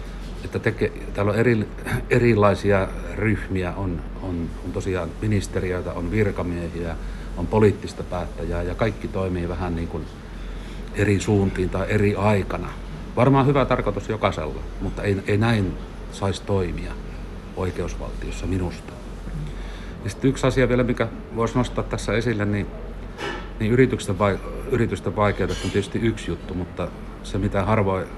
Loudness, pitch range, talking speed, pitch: -24 LUFS, 85-105 Hz, 135 wpm, 95 Hz